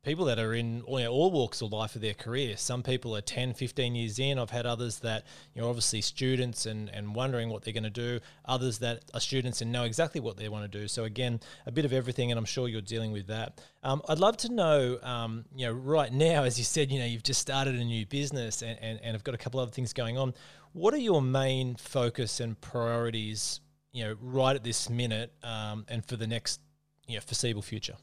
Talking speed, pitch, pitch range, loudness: 250 wpm, 120 Hz, 115-130 Hz, -31 LUFS